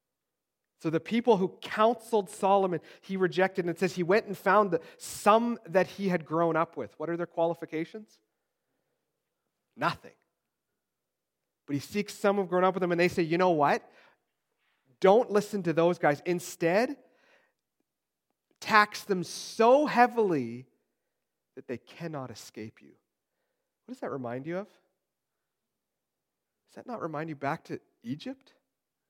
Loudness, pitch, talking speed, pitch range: -28 LUFS, 185 Hz, 150 wpm, 165-210 Hz